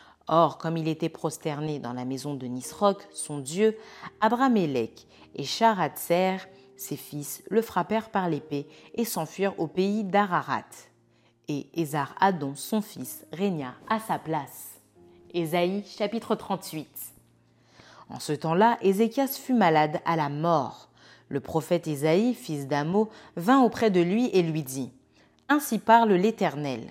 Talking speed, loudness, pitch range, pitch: 135 wpm, -27 LUFS, 145-210 Hz, 165 Hz